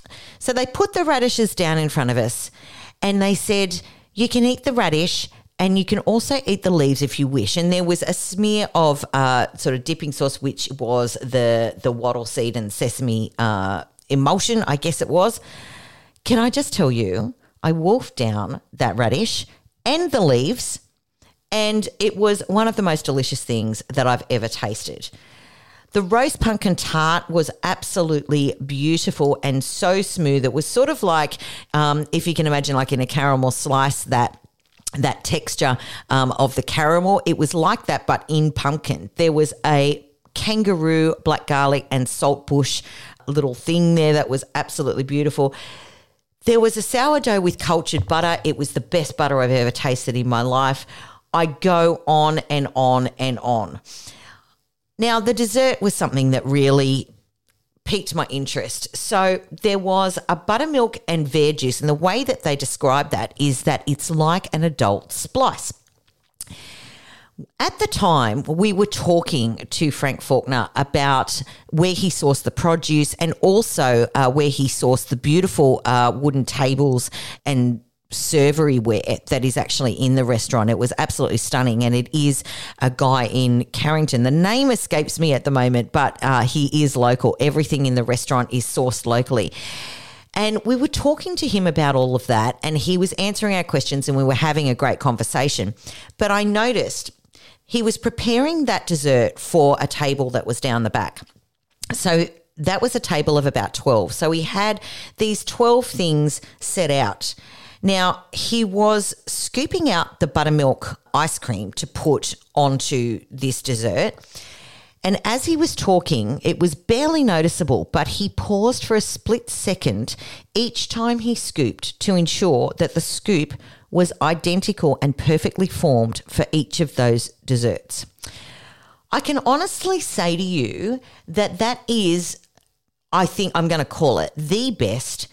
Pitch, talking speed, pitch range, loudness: 150 Hz, 165 wpm, 130-185 Hz, -20 LUFS